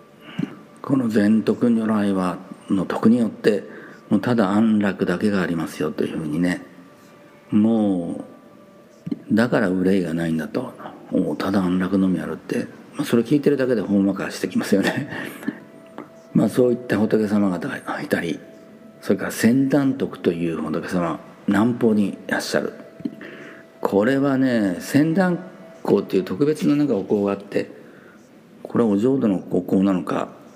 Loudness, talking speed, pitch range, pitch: -21 LUFS, 295 characters per minute, 95-135 Hz, 105 Hz